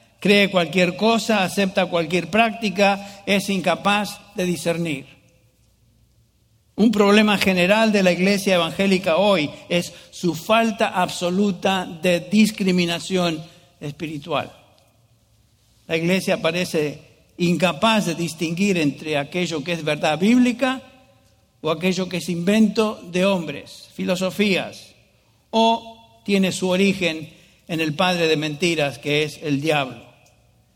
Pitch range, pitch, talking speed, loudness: 155-200 Hz, 180 Hz, 115 wpm, -20 LUFS